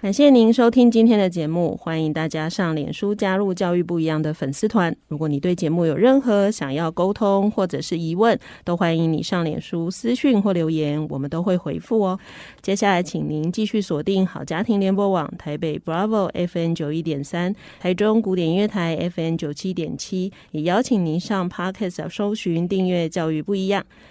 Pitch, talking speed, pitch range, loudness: 180 Hz, 320 characters per minute, 165-200 Hz, -21 LUFS